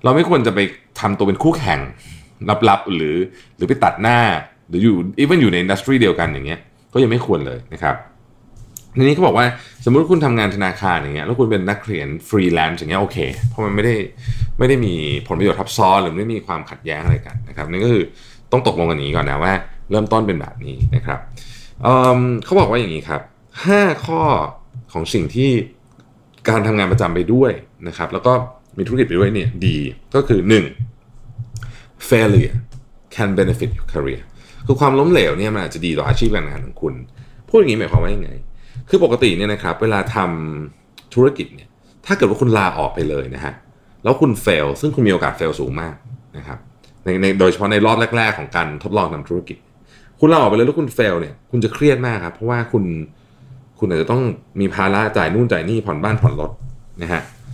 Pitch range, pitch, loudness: 95-125 Hz, 115 Hz, -17 LUFS